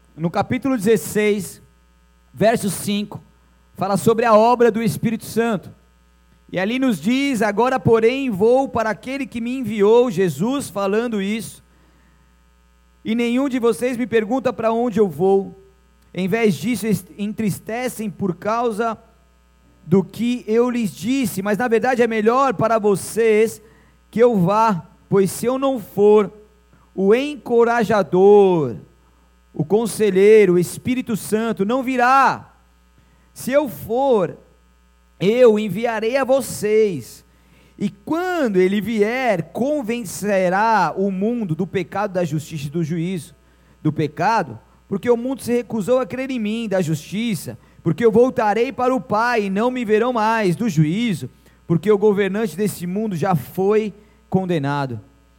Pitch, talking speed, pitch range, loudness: 210 Hz, 140 wpm, 175-235 Hz, -19 LUFS